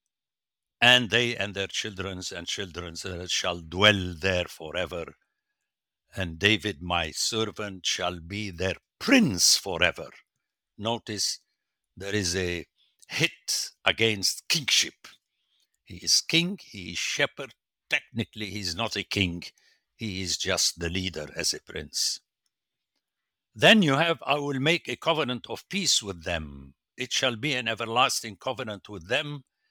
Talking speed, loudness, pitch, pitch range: 135 wpm, -26 LUFS, 105 Hz, 90-125 Hz